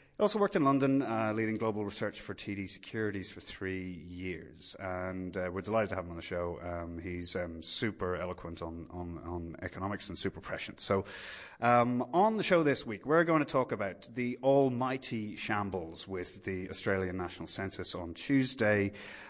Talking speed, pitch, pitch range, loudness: 180 wpm, 95 Hz, 90-115 Hz, -33 LUFS